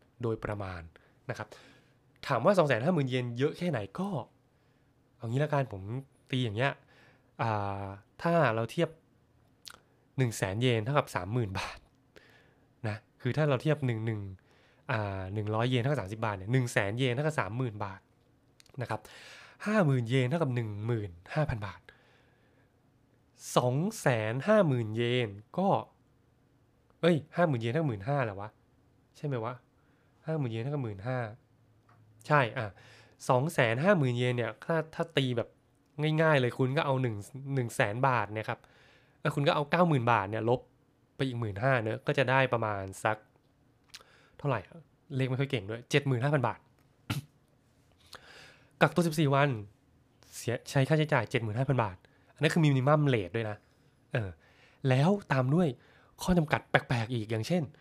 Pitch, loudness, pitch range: 125 Hz, -31 LUFS, 115-145 Hz